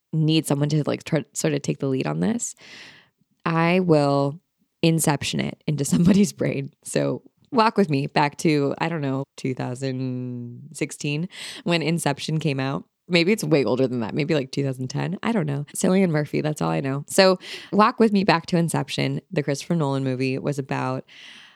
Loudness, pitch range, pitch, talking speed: -23 LUFS, 135-175 Hz, 150 Hz, 180 wpm